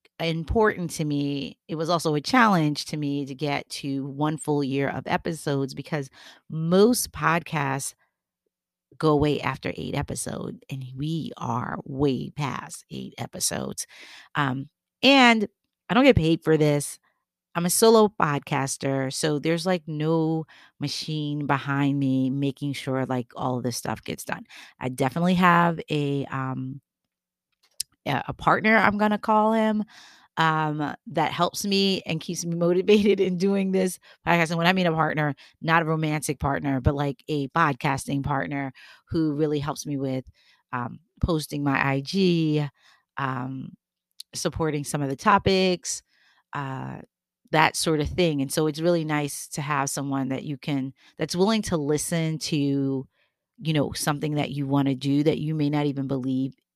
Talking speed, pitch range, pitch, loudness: 160 wpm, 140-170 Hz, 150 Hz, -25 LUFS